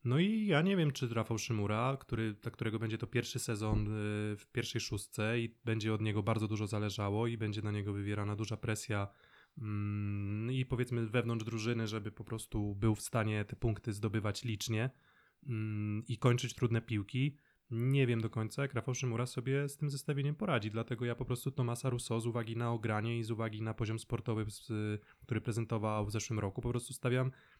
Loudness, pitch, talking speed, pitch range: -37 LUFS, 115 Hz, 190 wpm, 110-125 Hz